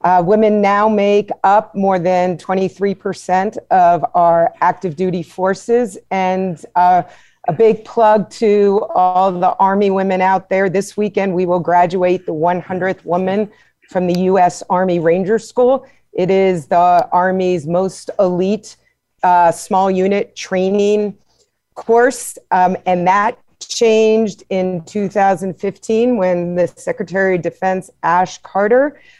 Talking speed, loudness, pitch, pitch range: 130 wpm, -15 LUFS, 190 Hz, 180-205 Hz